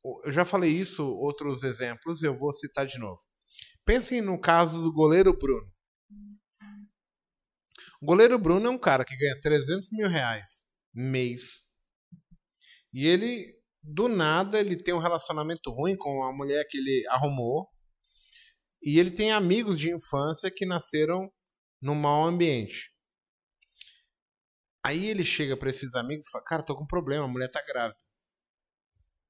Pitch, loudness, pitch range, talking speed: 160 Hz, -27 LUFS, 140-185 Hz, 145 wpm